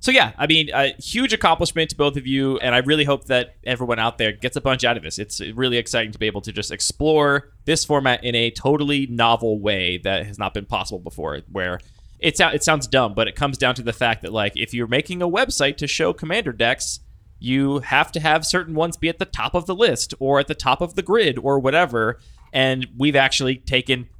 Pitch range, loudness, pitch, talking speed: 115-150 Hz, -20 LUFS, 130 Hz, 240 wpm